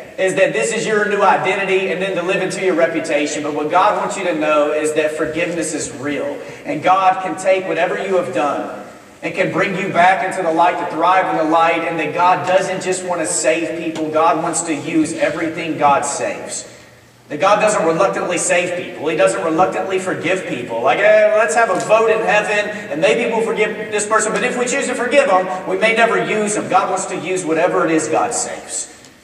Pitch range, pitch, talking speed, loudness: 165-200 Hz, 185 Hz, 225 wpm, -16 LUFS